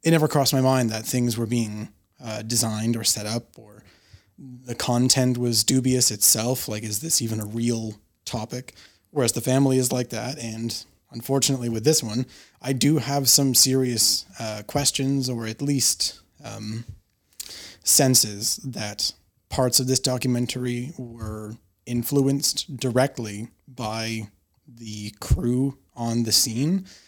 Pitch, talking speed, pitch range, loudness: 120 Hz, 140 wpm, 110-130 Hz, -22 LUFS